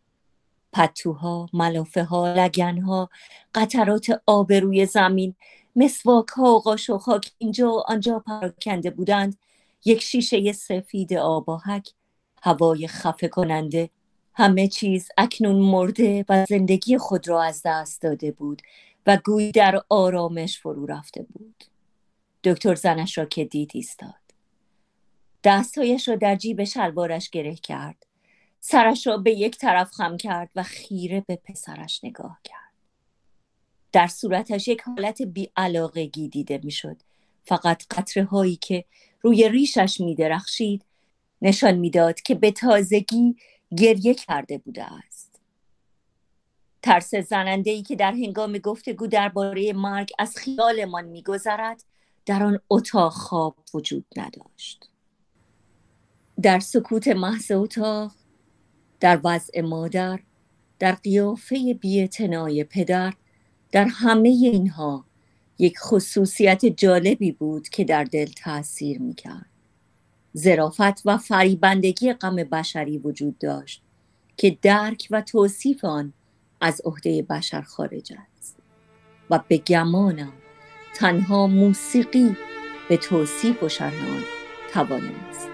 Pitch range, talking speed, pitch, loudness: 165-215 Hz, 115 wpm, 195 Hz, -22 LUFS